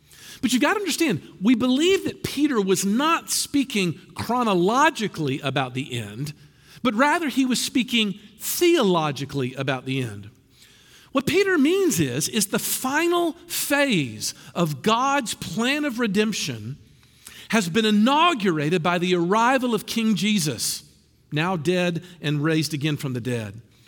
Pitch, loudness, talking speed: 200 Hz, -22 LUFS, 140 wpm